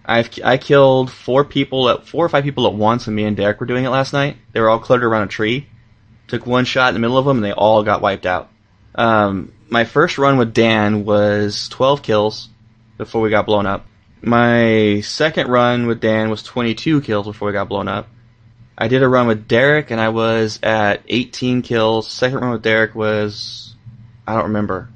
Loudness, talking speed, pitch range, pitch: -16 LUFS, 215 wpm, 105-125 Hz, 115 Hz